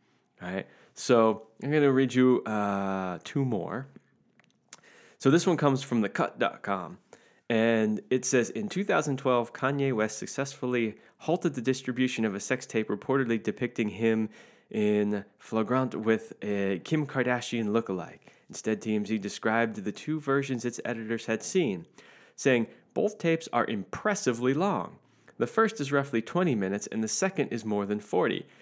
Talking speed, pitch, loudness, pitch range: 150 wpm, 125 Hz, -29 LUFS, 110-140 Hz